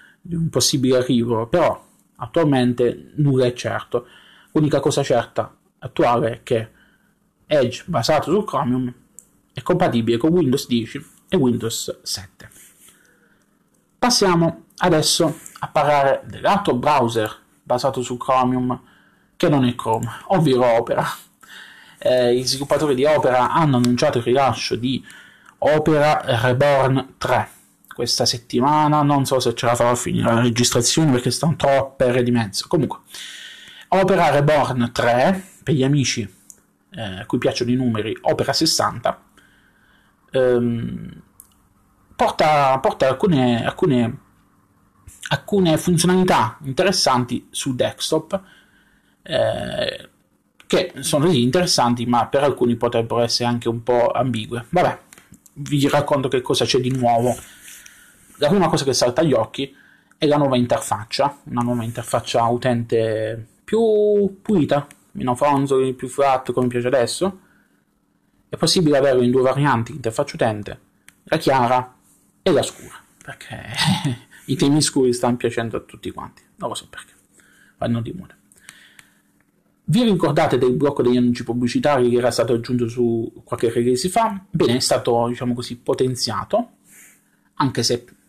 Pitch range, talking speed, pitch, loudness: 120-150 Hz, 135 wpm, 125 Hz, -19 LUFS